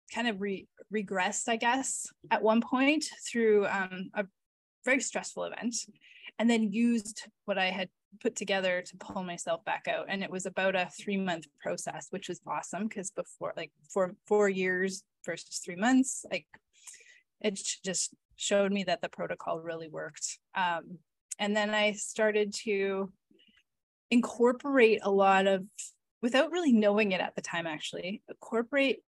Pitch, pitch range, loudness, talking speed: 205 Hz, 185-230 Hz, -31 LUFS, 155 wpm